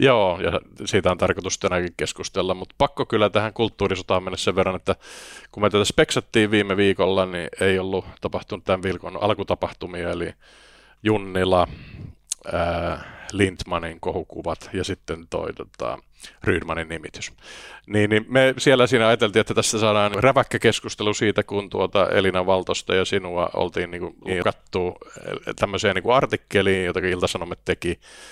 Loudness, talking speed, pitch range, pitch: -22 LUFS, 140 wpm, 95-110 Hz, 100 Hz